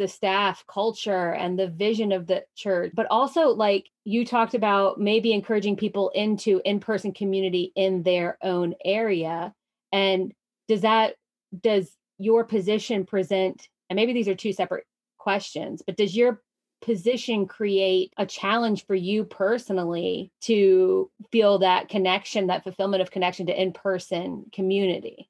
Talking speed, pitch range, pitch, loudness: 145 wpm, 190-220 Hz, 200 Hz, -24 LUFS